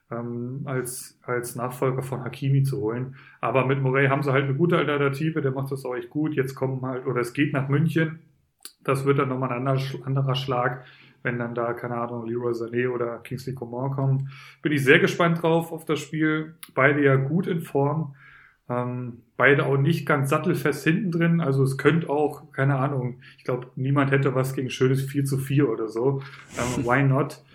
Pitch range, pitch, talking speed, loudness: 125-145 Hz, 135 Hz, 200 wpm, -24 LUFS